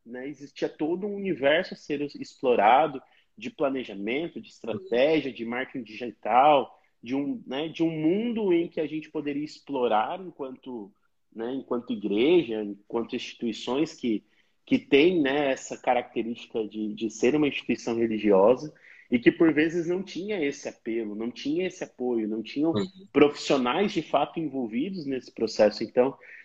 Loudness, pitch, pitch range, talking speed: -27 LUFS, 140 Hz, 120-165 Hz, 150 wpm